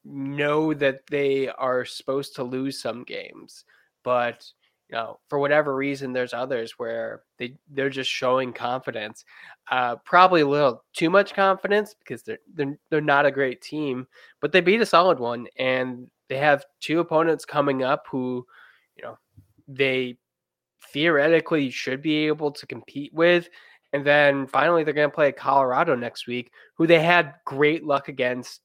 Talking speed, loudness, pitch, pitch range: 165 wpm, -23 LUFS, 140 Hz, 130-155 Hz